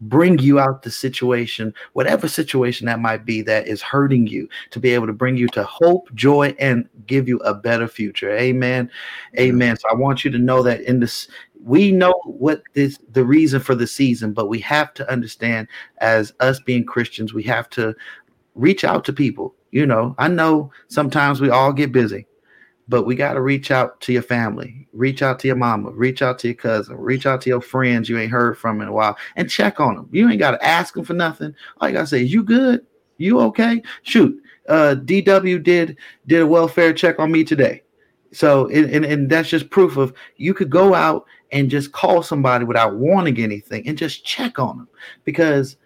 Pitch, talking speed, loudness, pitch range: 130 Hz, 215 wpm, -17 LUFS, 120-150 Hz